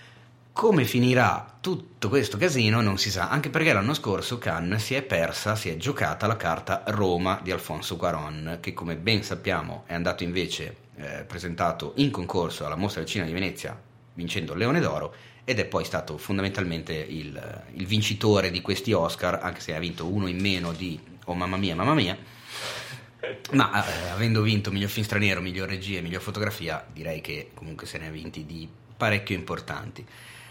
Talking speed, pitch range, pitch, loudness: 180 wpm, 85-110 Hz, 95 Hz, -27 LUFS